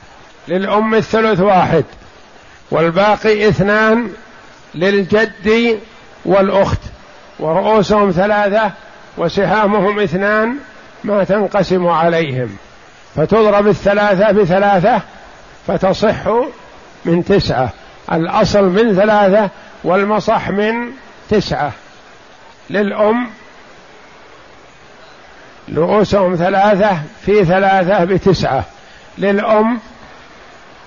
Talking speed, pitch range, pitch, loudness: 65 wpm, 190-215 Hz, 205 Hz, -14 LUFS